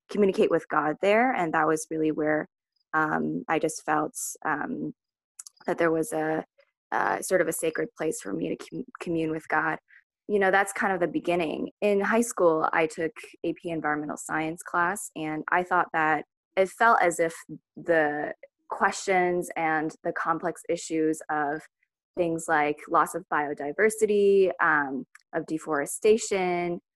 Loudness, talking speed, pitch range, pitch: -26 LUFS, 160 wpm, 155-190 Hz, 165 Hz